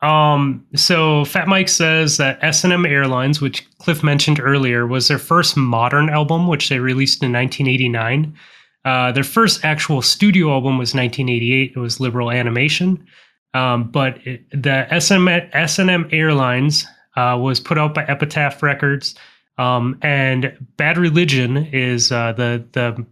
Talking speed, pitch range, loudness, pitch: 145 wpm, 130-155 Hz, -16 LUFS, 140 Hz